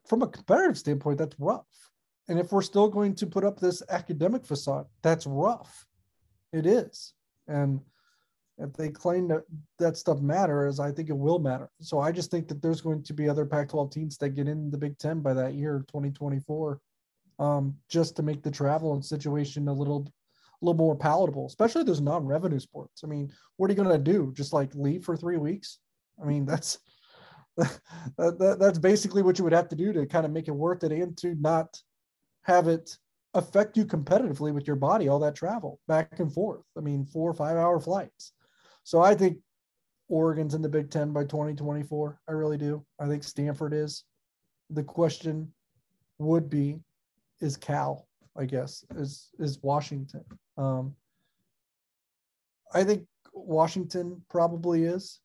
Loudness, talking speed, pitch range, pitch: -28 LUFS, 180 wpm, 145-175 Hz, 155 Hz